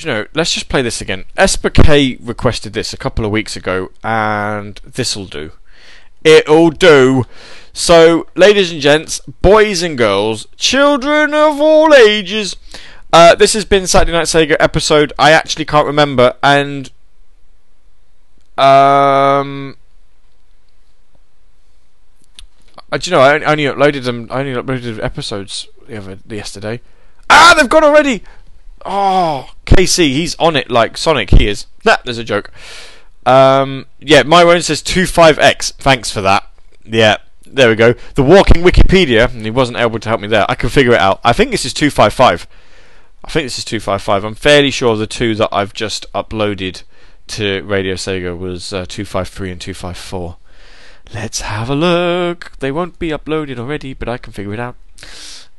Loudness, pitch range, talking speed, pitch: -12 LUFS, 105-160 Hz, 170 wpm, 130 Hz